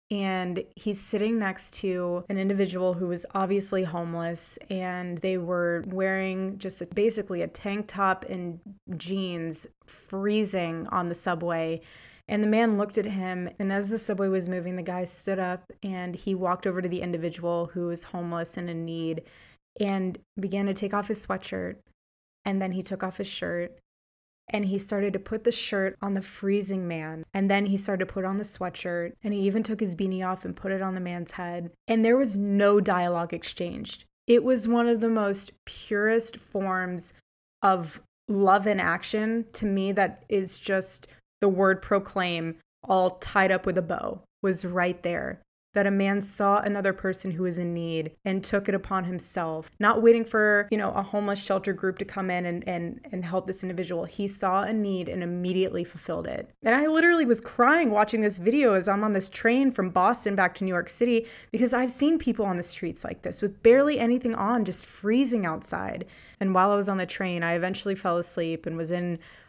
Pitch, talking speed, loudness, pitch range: 195 Hz, 200 wpm, -27 LUFS, 180-205 Hz